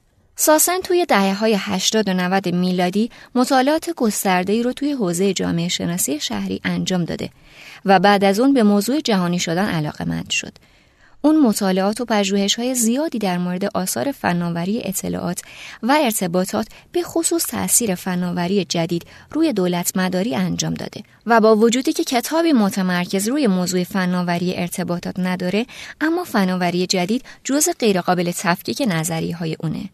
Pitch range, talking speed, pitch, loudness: 180-240 Hz, 145 wpm, 195 Hz, -19 LUFS